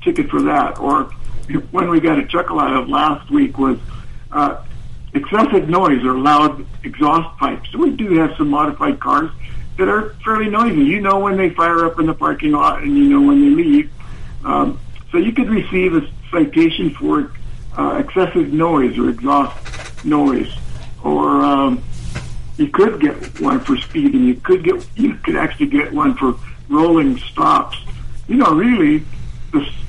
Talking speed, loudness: 175 wpm, -16 LUFS